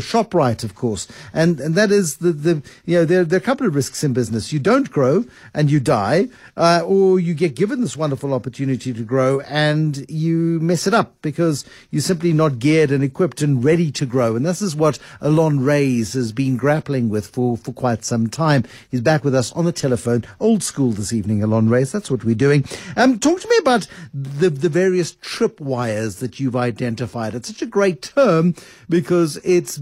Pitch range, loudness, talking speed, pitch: 125-175 Hz, -18 LUFS, 210 wpm, 150 Hz